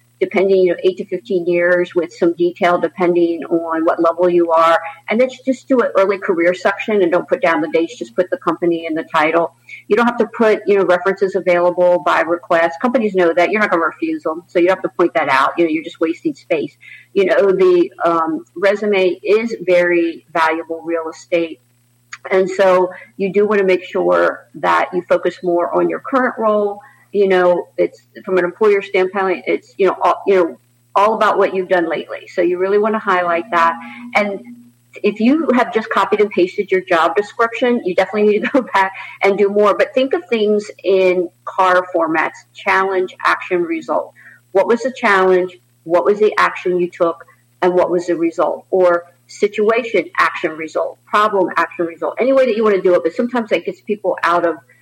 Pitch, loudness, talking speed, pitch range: 180 Hz, -16 LUFS, 205 wpm, 170-205 Hz